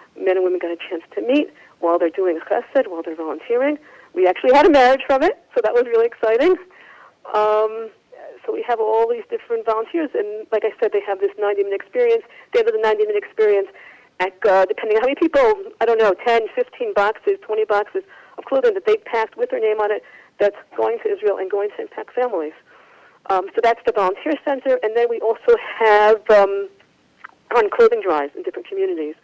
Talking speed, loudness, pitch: 205 wpm, -19 LUFS, 250 Hz